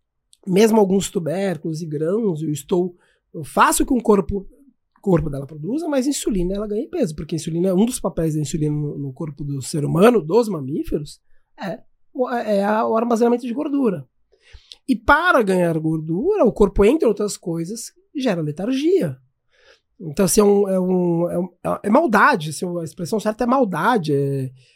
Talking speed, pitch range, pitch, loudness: 170 wpm, 165-235 Hz, 195 Hz, -20 LUFS